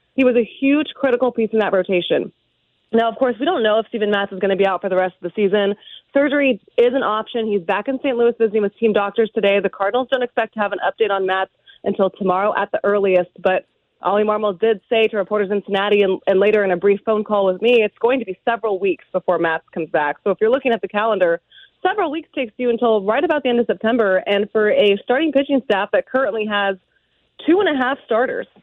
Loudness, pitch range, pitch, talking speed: -18 LUFS, 200-250 Hz, 215 Hz, 250 wpm